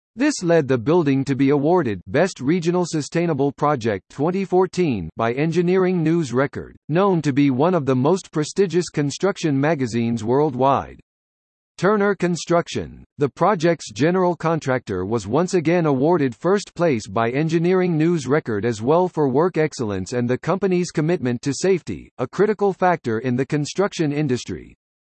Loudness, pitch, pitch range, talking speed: -20 LUFS, 155 Hz, 130-180 Hz, 145 wpm